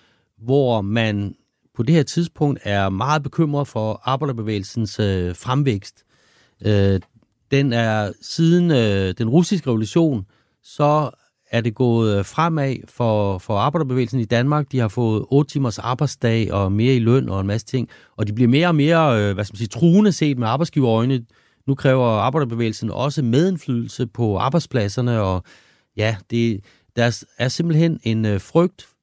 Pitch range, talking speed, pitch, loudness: 110-145 Hz, 145 wpm, 120 Hz, -20 LUFS